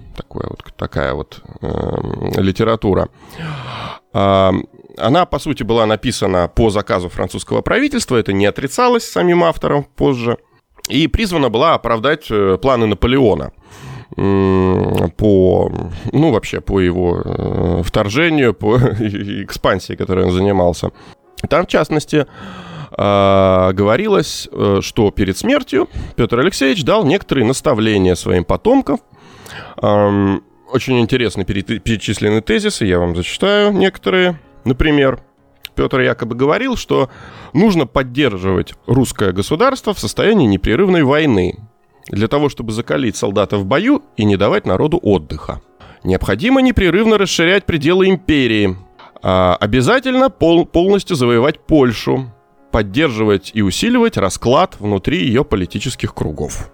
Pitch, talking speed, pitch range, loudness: 110 Hz, 115 wpm, 95-145 Hz, -15 LUFS